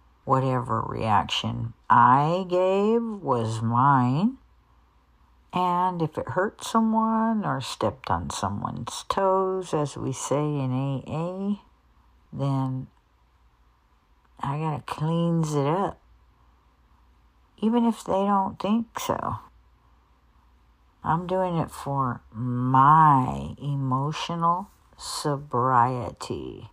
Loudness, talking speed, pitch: -25 LUFS, 90 wpm, 135 Hz